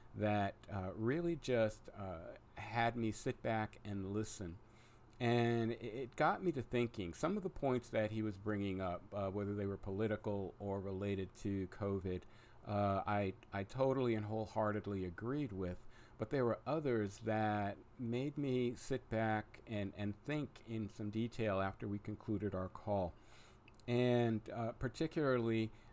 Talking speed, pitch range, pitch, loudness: 155 wpm, 100-120 Hz, 110 Hz, -40 LUFS